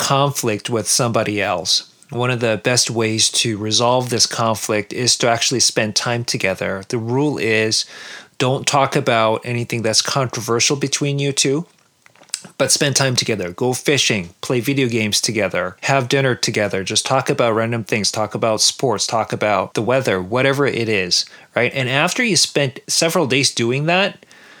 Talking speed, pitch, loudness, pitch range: 165 wpm, 120 Hz, -17 LUFS, 110-140 Hz